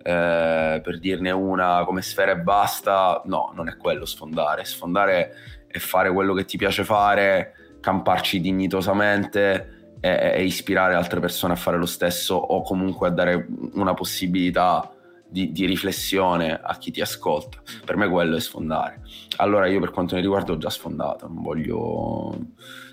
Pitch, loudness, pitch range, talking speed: 95 Hz, -22 LUFS, 90-95 Hz, 155 wpm